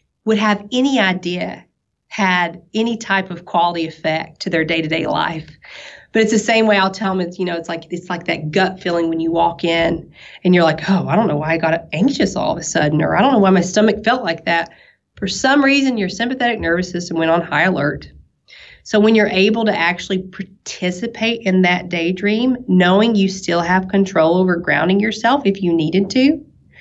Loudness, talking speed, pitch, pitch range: -16 LUFS, 210 wpm, 185 Hz, 170-215 Hz